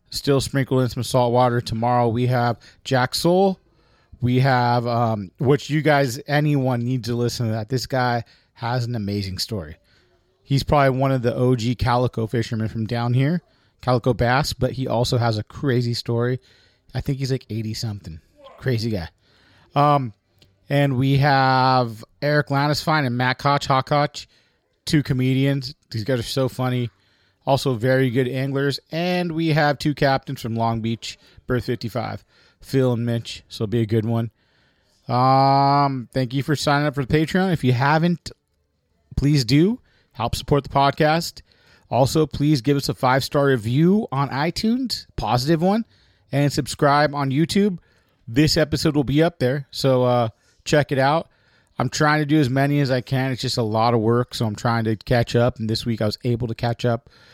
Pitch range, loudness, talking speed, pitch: 115-140 Hz, -21 LUFS, 180 wpm, 125 Hz